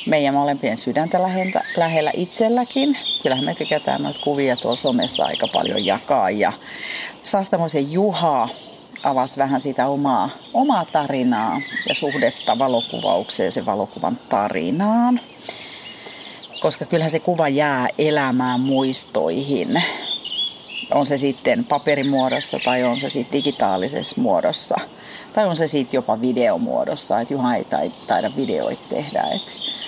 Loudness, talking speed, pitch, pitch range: -20 LUFS, 120 wpm, 145 Hz, 135-180 Hz